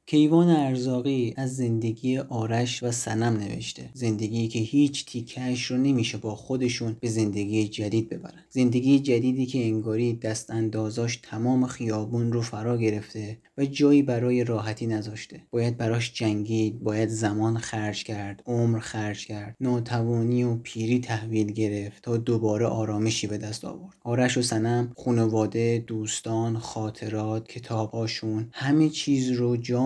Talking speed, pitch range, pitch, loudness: 135 wpm, 110-125 Hz, 115 Hz, -26 LUFS